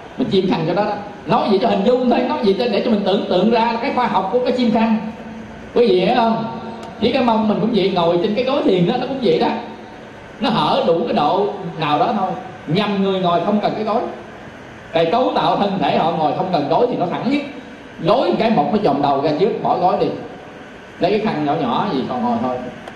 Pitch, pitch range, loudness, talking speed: 225 Hz, 190-245 Hz, -17 LUFS, 255 wpm